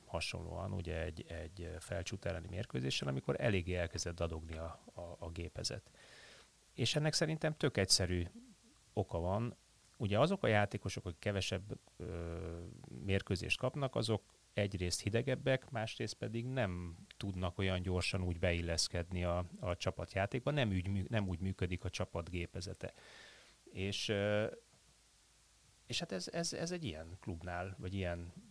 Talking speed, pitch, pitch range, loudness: 135 wpm, 95 Hz, 90-110 Hz, -39 LUFS